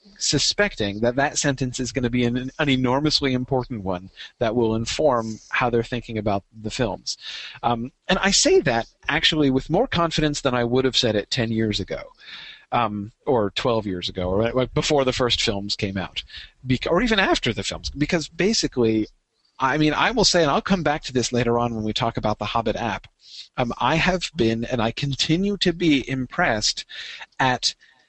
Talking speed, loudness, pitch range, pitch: 195 wpm, -22 LUFS, 115-150 Hz, 125 Hz